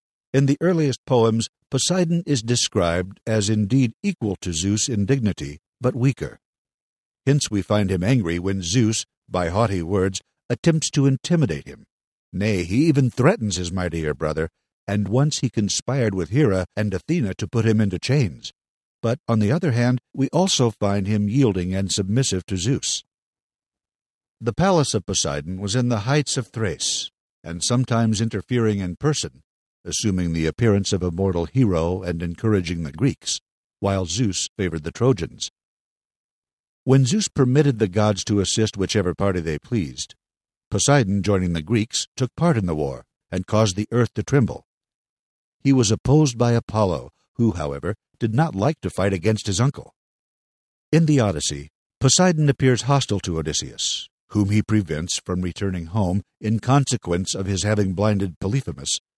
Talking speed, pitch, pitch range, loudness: 160 wpm, 110 Hz, 95-130 Hz, -22 LUFS